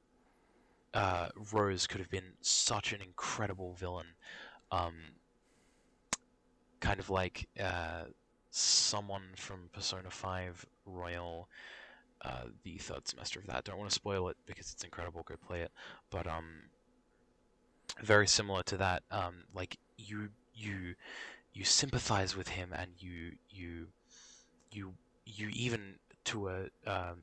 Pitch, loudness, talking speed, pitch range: 95 Hz, -37 LUFS, 130 wpm, 90-105 Hz